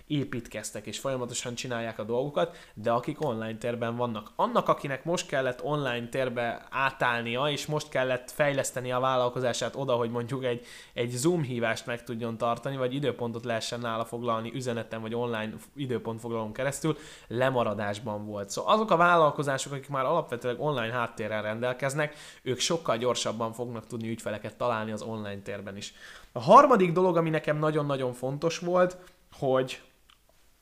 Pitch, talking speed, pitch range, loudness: 125 Hz, 150 wpm, 115-145 Hz, -29 LUFS